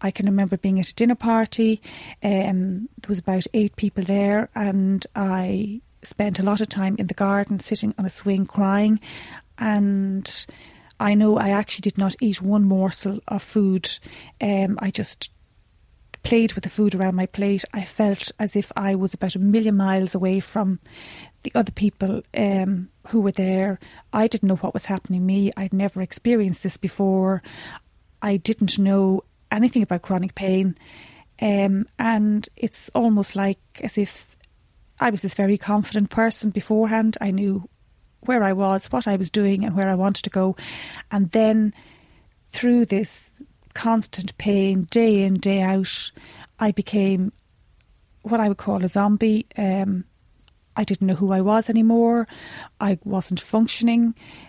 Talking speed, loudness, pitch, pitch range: 165 wpm, -22 LUFS, 200 Hz, 195-215 Hz